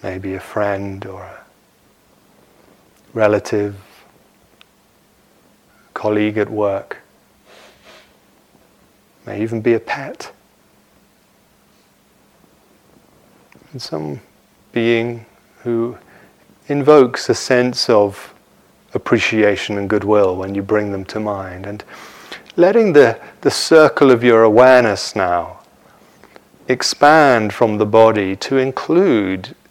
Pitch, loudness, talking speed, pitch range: 105 Hz, -15 LUFS, 95 wpm, 100-120 Hz